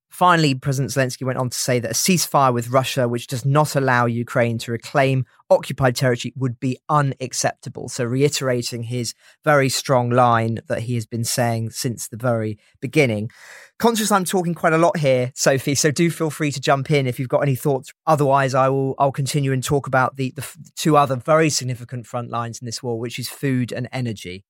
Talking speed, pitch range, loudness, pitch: 205 wpm, 120-145 Hz, -20 LUFS, 130 Hz